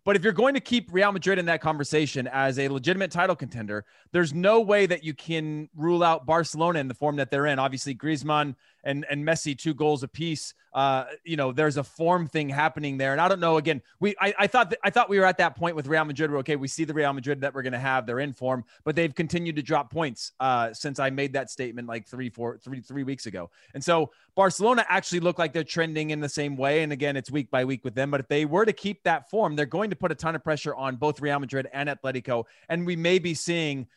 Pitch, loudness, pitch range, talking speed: 150 Hz, -26 LUFS, 135-170 Hz, 265 wpm